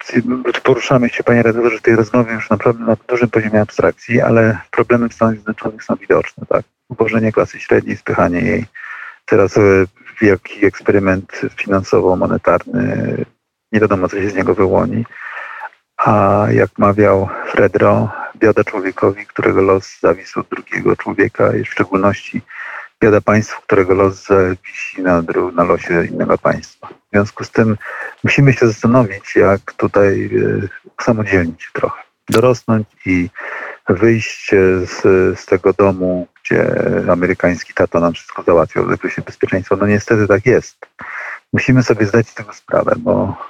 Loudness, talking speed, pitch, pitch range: -14 LUFS, 140 wpm, 110 Hz, 95-115 Hz